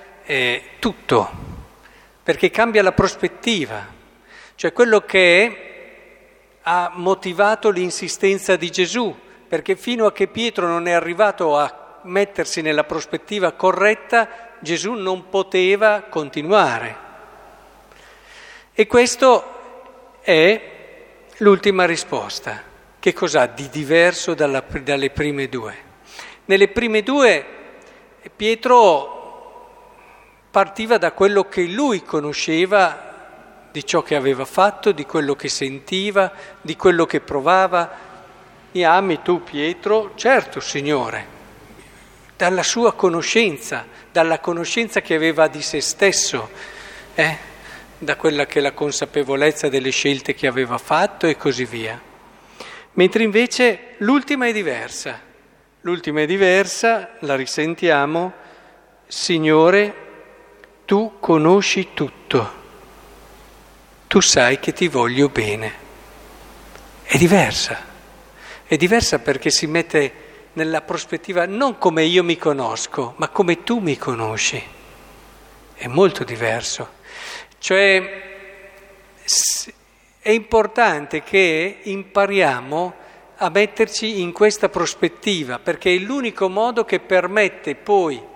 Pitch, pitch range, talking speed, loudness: 185 Hz, 160-215 Hz, 105 wpm, -18 LUFS